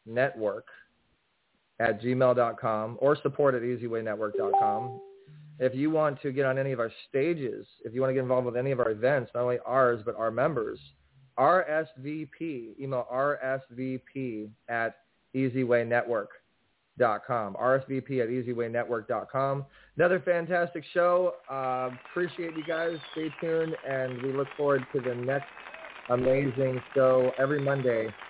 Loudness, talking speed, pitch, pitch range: -29 LUFS, 130 wpm, 130 Hz, 125-145 Hz